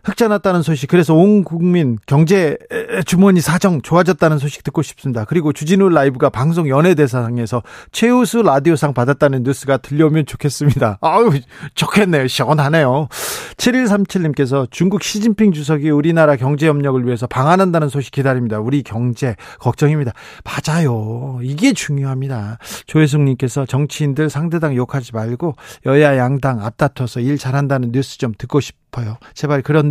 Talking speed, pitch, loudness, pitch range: 365 characters per minute, 145 Hz, -15 LUFS, 130-170 Hz